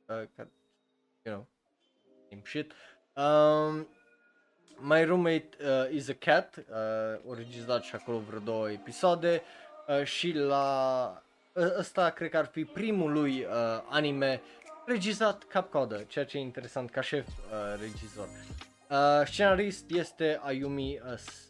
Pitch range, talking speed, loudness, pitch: 120-170 Hz, 130 wpm, -31 LUFS, 140 Hz